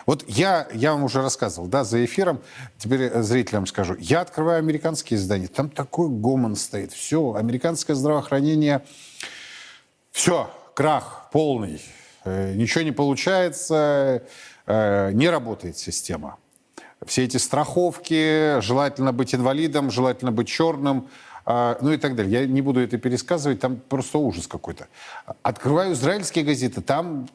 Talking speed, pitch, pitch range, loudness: 125 wpm, 135 Hz, 120-155 Hz, -22 LUFS